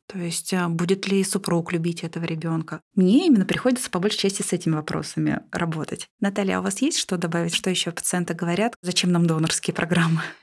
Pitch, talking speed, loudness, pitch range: 175 Hz, 190 wpm, -23 LUFS, 170-195 Hz